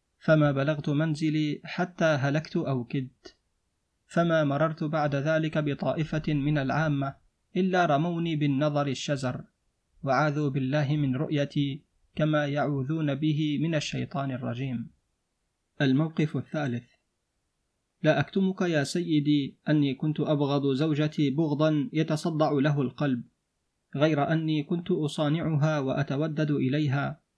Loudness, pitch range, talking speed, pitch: -27 LUFS, 140-155 Hz, 105 wpm, 150 Hz